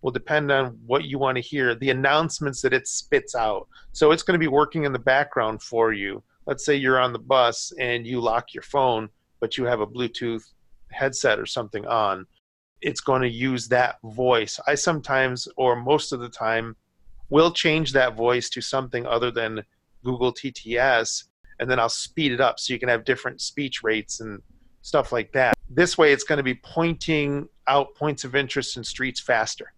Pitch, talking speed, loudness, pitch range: 125 Hz, 200 wpm, -23 LUFS, 115-140 Hz